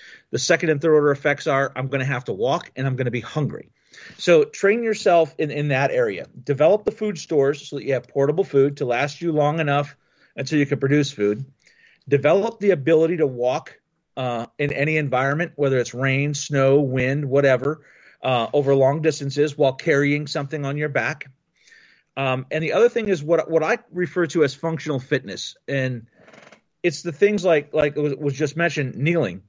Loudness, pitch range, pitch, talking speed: -21 LUFS, 135-160 Hz, 145 Hz, 200 wpm